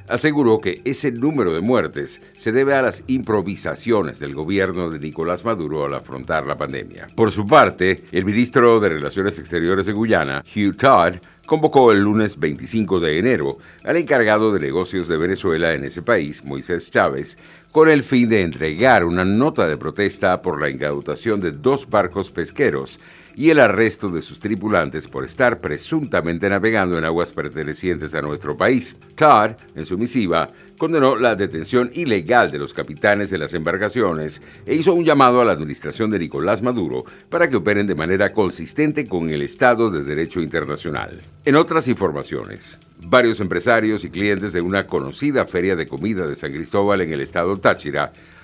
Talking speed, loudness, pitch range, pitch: 170 wpm, -19 LUFS, 80-115 Hz, 100 Hz